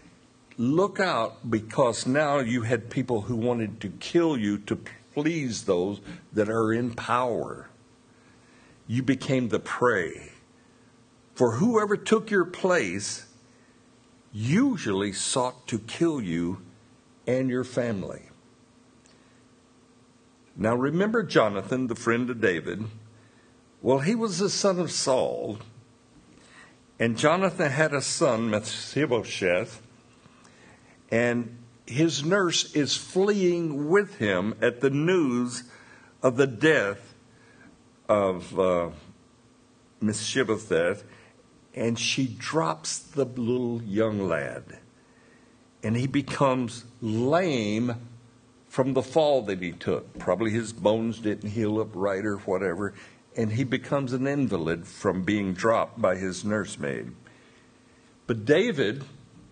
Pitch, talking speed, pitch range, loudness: 120 Hz, 115 wpm, 110-140 Hz, -26 LUFS